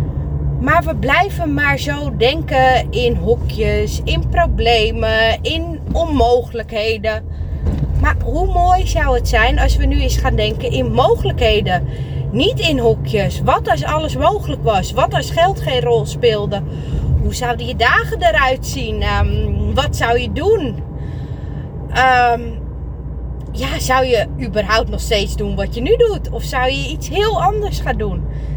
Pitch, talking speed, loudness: 230 Hz, 150 wpm, -16 LUFS